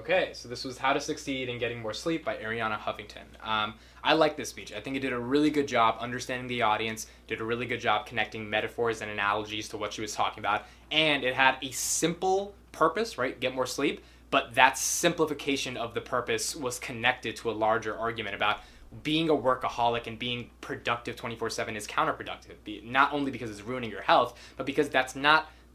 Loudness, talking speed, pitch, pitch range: -29 LUFS, 205 wpm, 120 Hz, 110-140 Hz